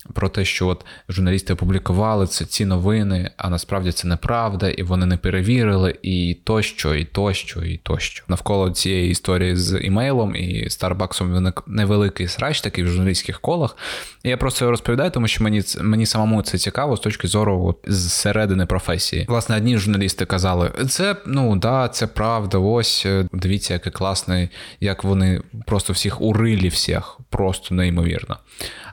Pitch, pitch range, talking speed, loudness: 95 Hz, 90-110 Hz, 160 wpm, -20 LUFS